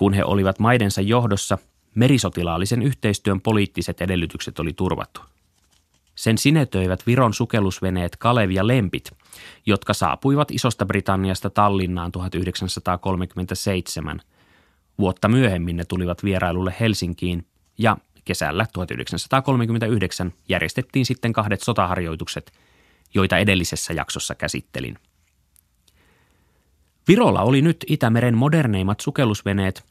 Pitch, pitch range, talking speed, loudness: 95 Hz, 85-115 Hz, 90 wpm, -21 LUFS